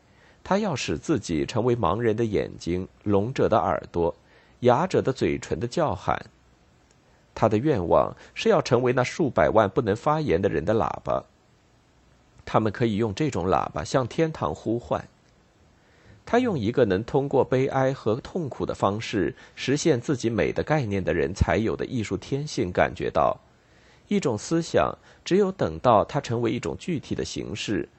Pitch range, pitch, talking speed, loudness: 100-145 Hz, 120 Hz, 240 characters per minute, -25 LUFS